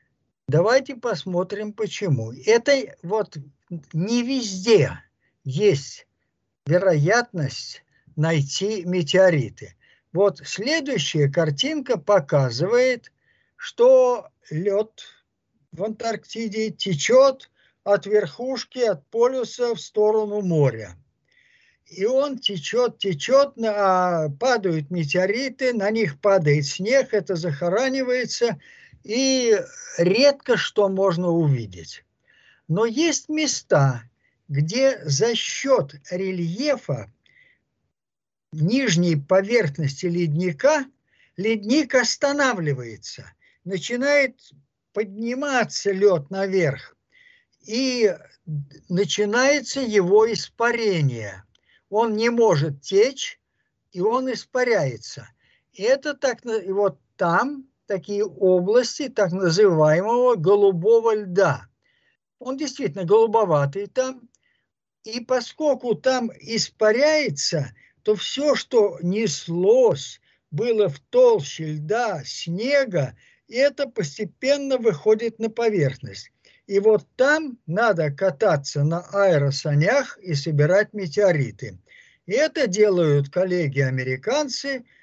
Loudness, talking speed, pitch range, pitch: -21 LUFS, 85 wpm, 165-255 Hz, 210 Hz